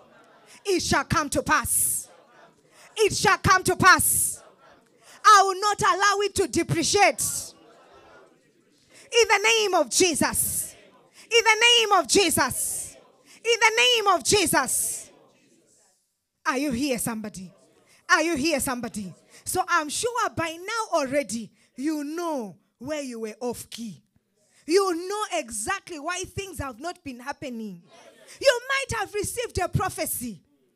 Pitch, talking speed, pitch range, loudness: 330 Hz, 135 wpm, 270-395 Hz, -22 LUFS